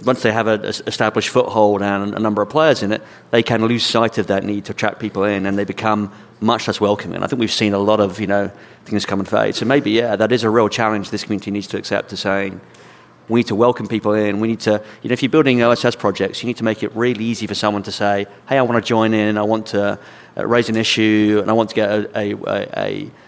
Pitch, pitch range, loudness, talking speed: 110 Hz, 105-115 Hz, -18 LUFS, 275 wpm